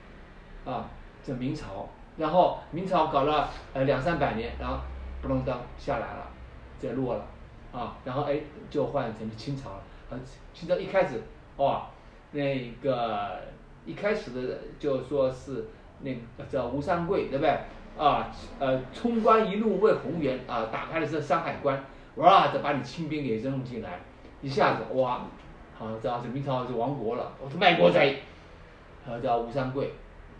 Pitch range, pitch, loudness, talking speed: 100-140 Hz, 130 Hz, -28 LUFS, 225 characters per minute